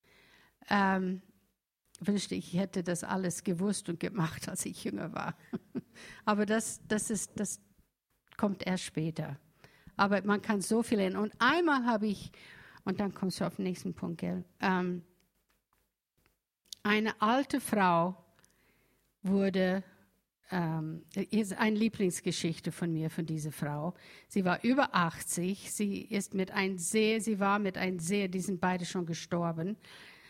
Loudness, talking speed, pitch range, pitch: -33 LUFS, 145 wpm, 175-205 Hz, 190 Hz